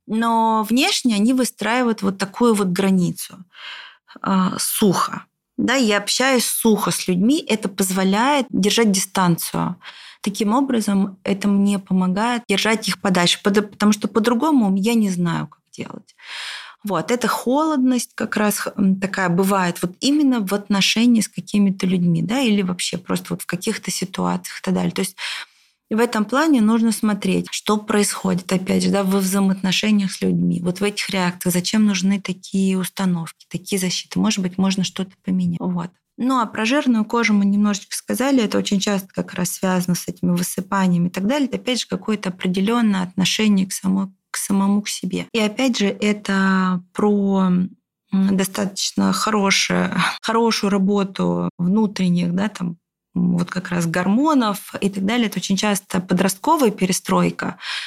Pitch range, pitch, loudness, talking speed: 185-220 Hz, 200 Hz, -19 LUFS, 155 wpm